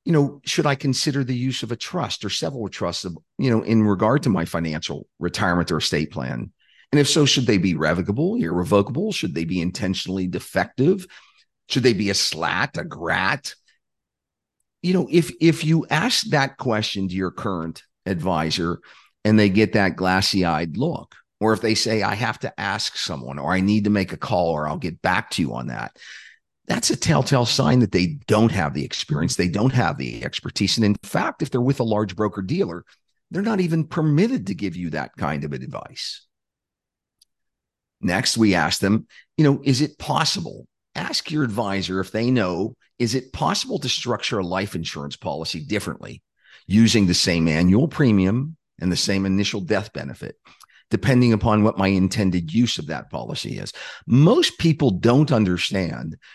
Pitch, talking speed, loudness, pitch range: 105 Hz, 185 wpm, -21 LUFS, 90-135 Hz